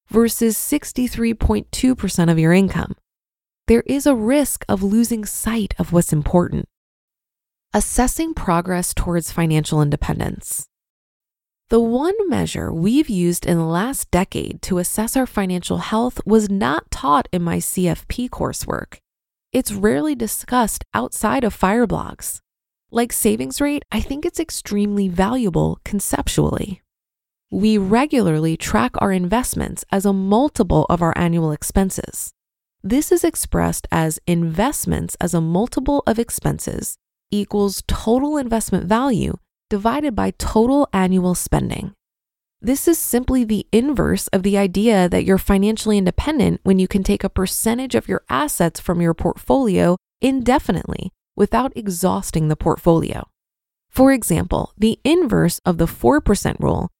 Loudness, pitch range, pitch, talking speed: -19 LUFS, 180-245 Hz, 210 Hz, 135 wpm